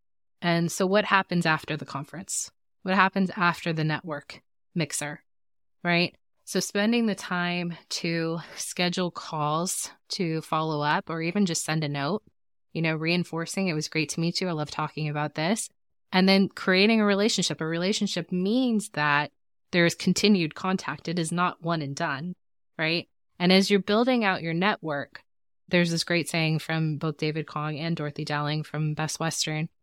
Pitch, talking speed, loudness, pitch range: 165 Hz, 170 wpm, -26 LUFS, 155-185 Hz